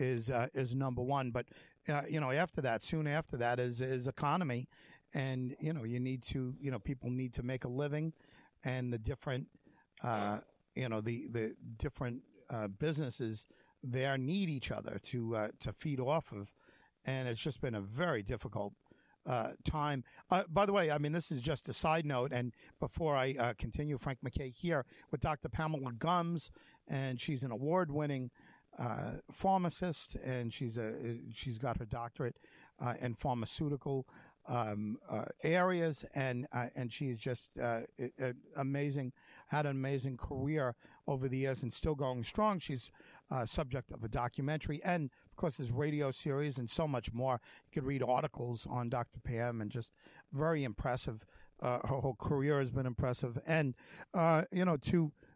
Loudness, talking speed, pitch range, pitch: -38 LUFS, 180 wpm, 120-150 Hz, 135 Hz